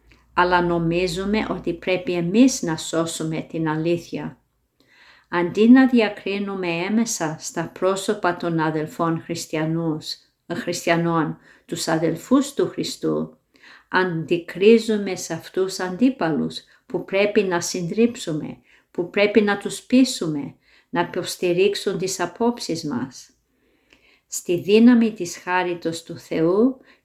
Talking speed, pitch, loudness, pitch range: 105 wpm, 180 Hz, -21 LUFS, 165-210 Hz